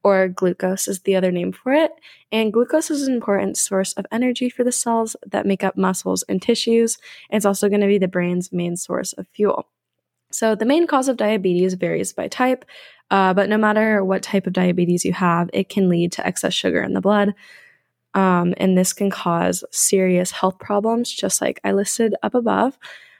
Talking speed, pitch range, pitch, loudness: 200 wpm, 185-230 Hz, 200 Hz, -19 LUFS